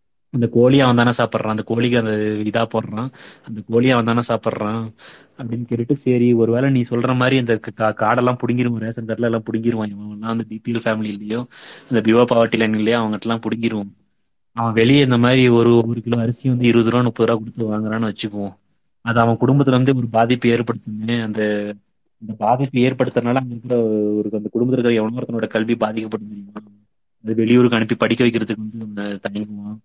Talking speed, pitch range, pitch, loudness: 160 wpm, 110-120 Hz, 115 Hz, -18 LUFS